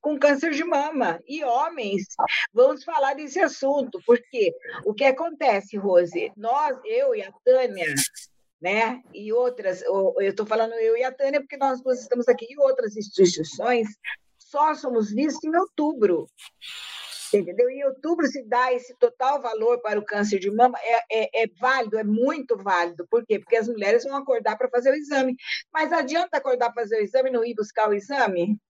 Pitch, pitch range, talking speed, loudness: 255 Hz, 225-300 Hz, 185 wpm, -23 LUFS